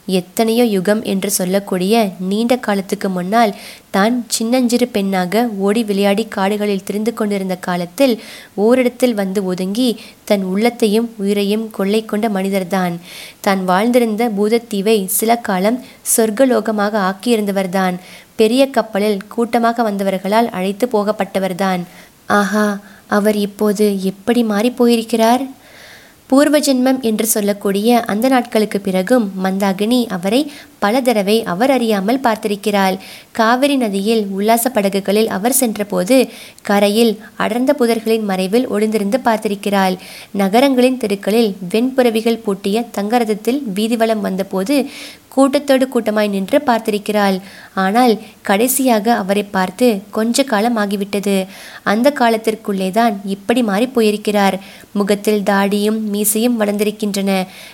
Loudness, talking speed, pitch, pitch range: -16 LUFS, 100 wpm, 215 Hz, 200-235 Hz